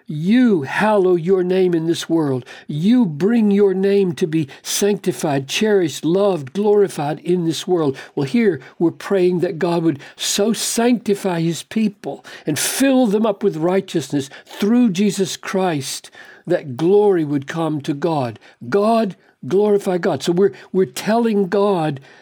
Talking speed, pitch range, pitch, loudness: 145 wpm, 165-205 Hz, 185 Hz, -18 LUFS